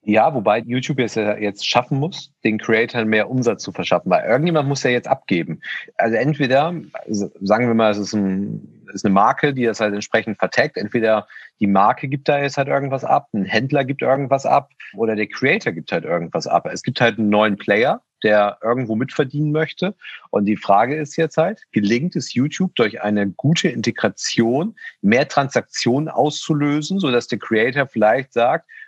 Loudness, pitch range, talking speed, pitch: -19 LUFS, 110-150 Hz, 190 wpm, 125 Hz